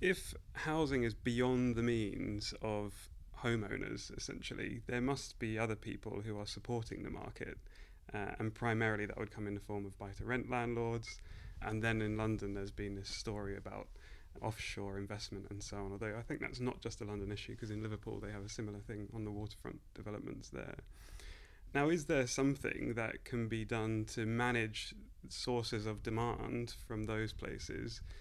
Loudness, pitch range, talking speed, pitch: -40 LUFS, 100-115 Hz, 180 wpm, 110 Hz